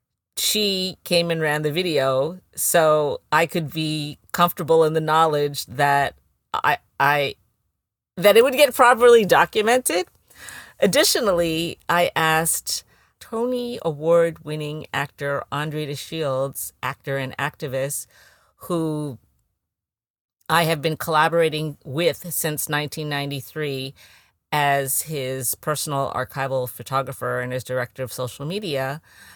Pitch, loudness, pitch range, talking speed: 150 Hz, -21 LUFS, 135-165 Hz, 115 wpm